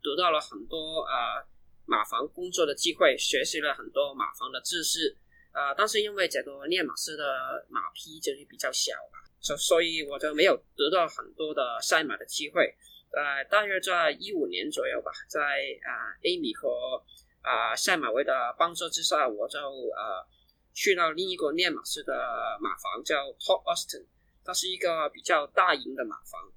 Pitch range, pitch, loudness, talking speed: 315-445 Hz, 380 Hz, -28 LUFS, 270 characters per minute